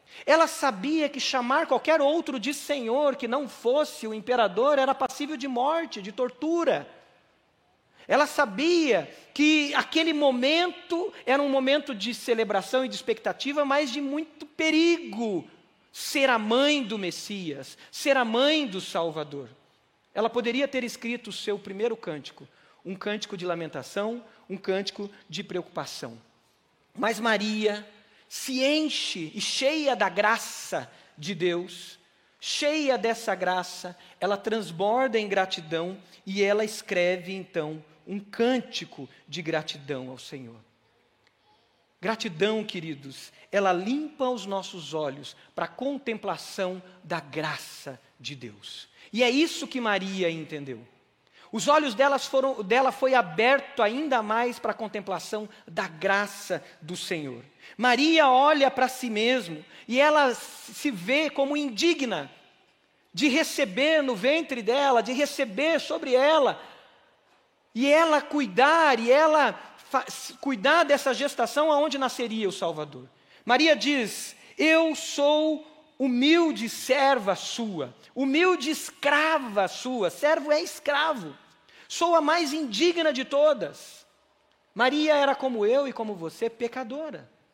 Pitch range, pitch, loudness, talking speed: 195-290 Hz, 245 Hz, -25 LUFS, 125 wpm